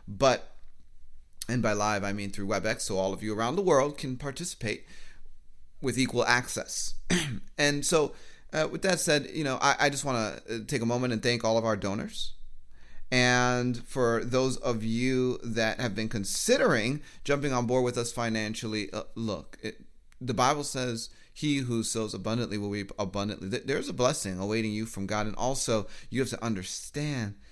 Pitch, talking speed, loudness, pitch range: 115 Hz, 180 wpm, -29 LUFS, 105-130 Hz